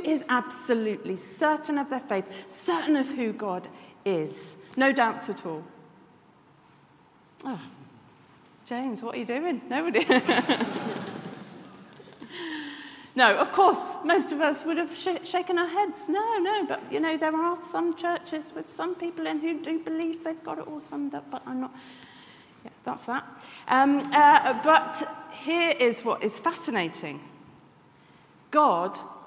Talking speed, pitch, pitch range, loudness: 145 wpm, 305 Hz, 250-335 Hz, -26 LUFS